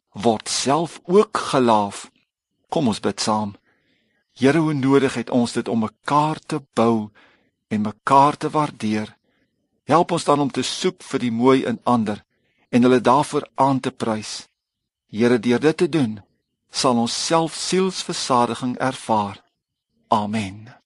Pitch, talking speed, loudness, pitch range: 125 Hz, 145 wpm, -20 LUFS, 110-145 Hz